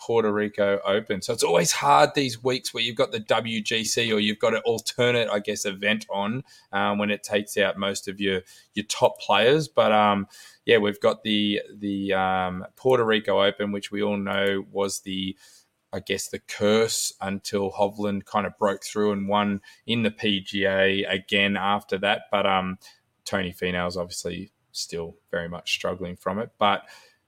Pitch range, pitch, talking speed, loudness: 100-105 Hz, 100 Hz, 180 wpm, -24 LUFS